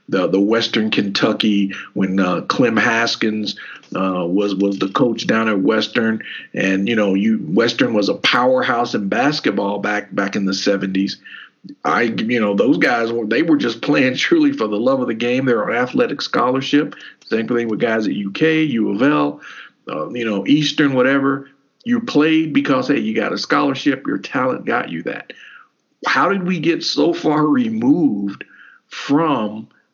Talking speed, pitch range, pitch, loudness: 175 wpm, 100-150 Hz, 120 Hz, -17 LUFS